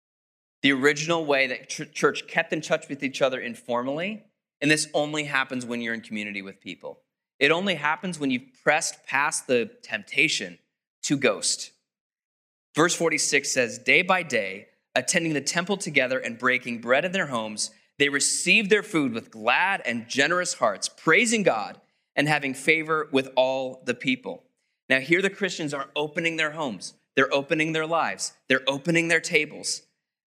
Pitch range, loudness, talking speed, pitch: 130-170 Hz, -24 LUFS, 165 wpm, 150 Hz